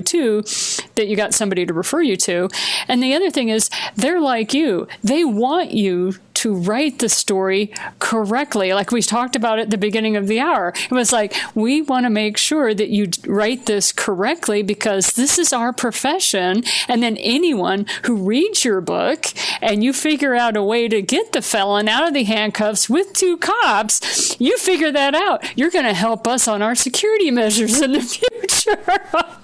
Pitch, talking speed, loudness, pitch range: 230 Hz, 190 wpm, -17 LUFS, 210-295 Hz